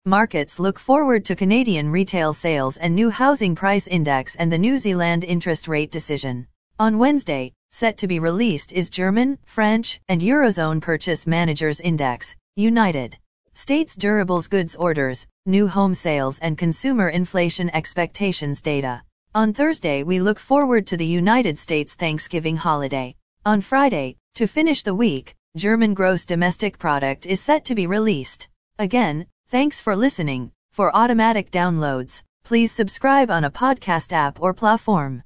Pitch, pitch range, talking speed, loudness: 185 Hz, 160-220 Hz, 150 wpm, -20 LUFS